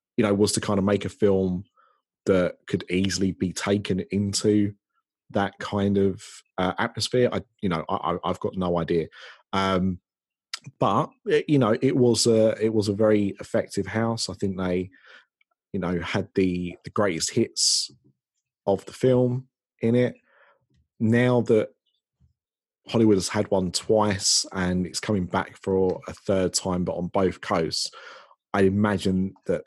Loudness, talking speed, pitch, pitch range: -24 LUFS, 160 wpm, 100 Hz, 95-110 Hz